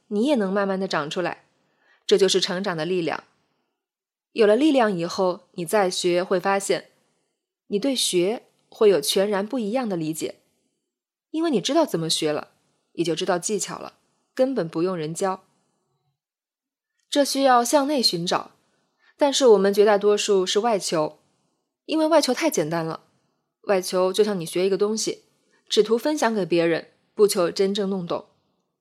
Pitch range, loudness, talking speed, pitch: 180-265 Hz, -22 LUFS, 235 characters per minute, 200 Hz